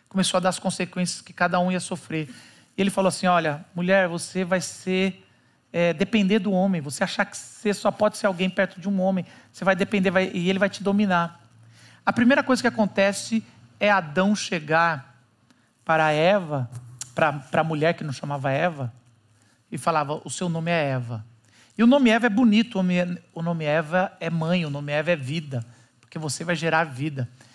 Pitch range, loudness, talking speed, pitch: 145-195 Hz, -23 LUFS, 190 wpm, 175 Hz